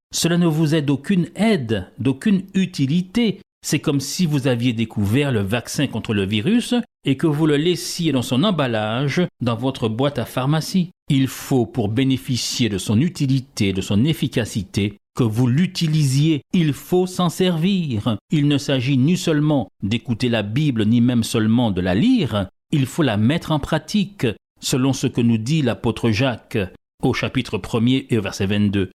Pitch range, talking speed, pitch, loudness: 115-160 Hz, 170 wpm, 135 Hz, -20 LUFS